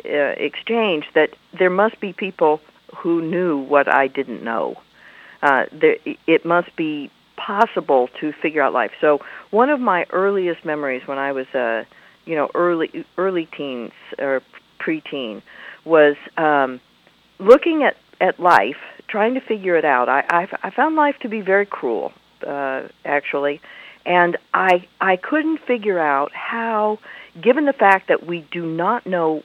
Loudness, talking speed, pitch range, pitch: -19 LUFS, 155 wpm, 150-225 Hz, 175 Hz